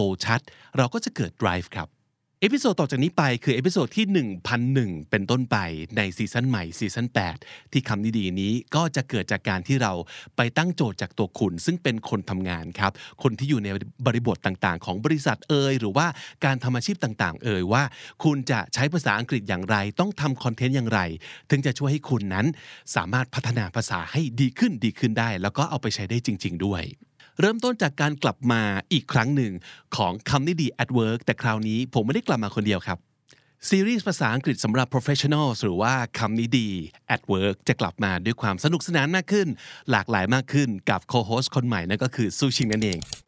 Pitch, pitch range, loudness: 120 Hz, 105-140 Hz, -25 LUFS